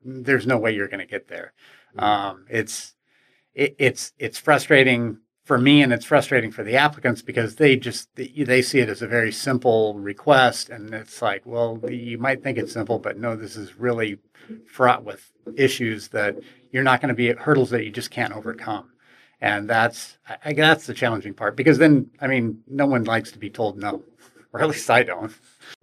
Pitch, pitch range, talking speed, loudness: 120 Hz, 110-130 Hz, 195 wpm, -21 LUFS